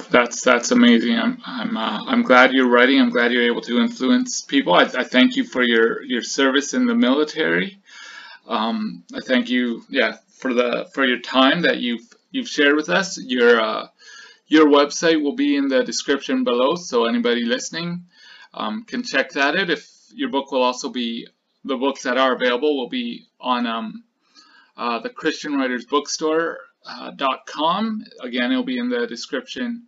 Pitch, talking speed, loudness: 165 Hz, 185 wpm, -19 LUFS